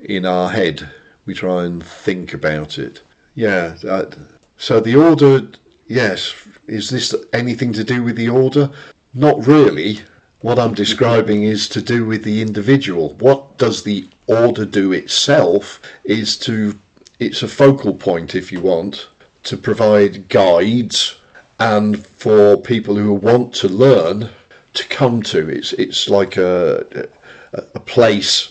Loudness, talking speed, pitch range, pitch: -15 LUFS, 145 wpm, 105-130 Hz, 110 Hz